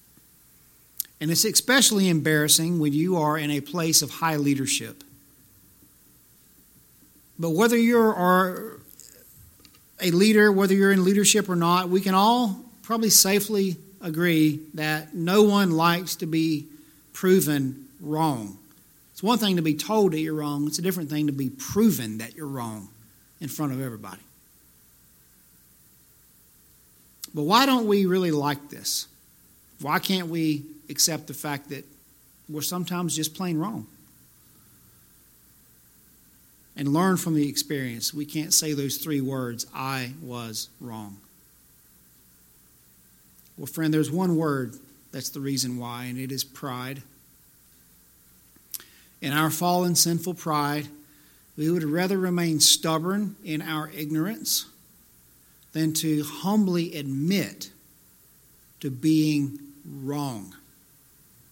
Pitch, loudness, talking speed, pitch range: 150 Hz, -23 LUFS, 125 wpm, 135-175 Hz